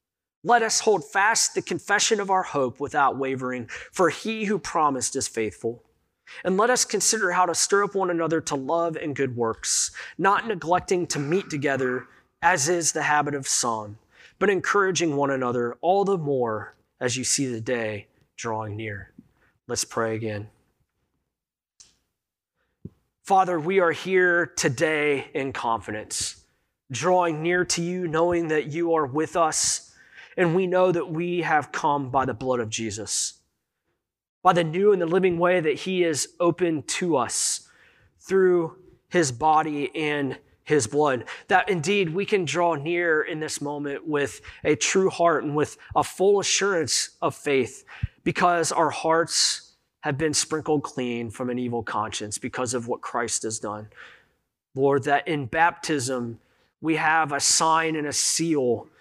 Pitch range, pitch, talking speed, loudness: 130-180 Hz, 155 Hz, 160 wpm, -24 LUFS